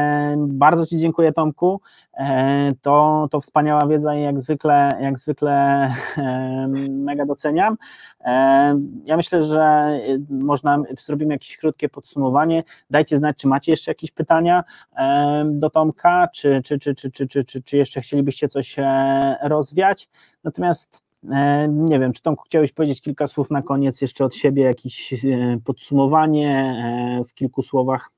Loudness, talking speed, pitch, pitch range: -19 LUFS, 130 wpm, 145 Hz, 135-155 Hz